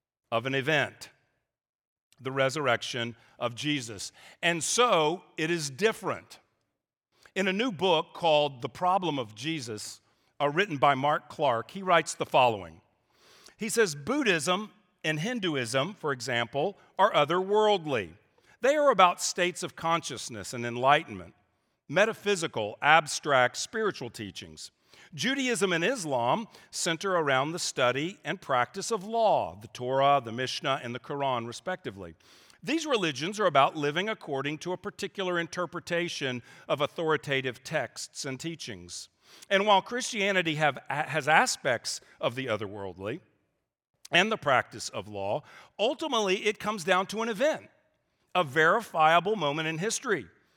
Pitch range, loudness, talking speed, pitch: 125-190 Hz, -28 LUFS, 130 wpm, 155 Hz